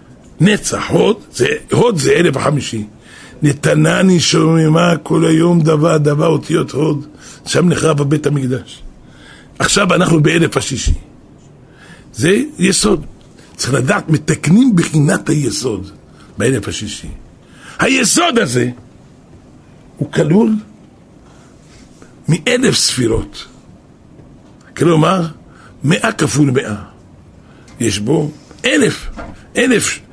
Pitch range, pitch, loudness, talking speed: 120-170 Hz, 155 Hz, -13 LUFS, 90 wpm